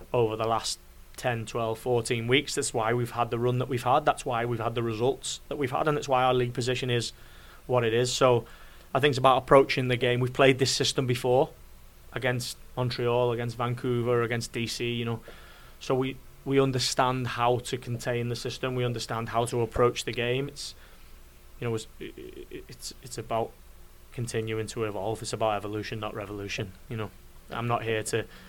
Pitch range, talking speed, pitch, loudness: 115-125 Hz, 195 wpm, 120 Hz, -28 LUFS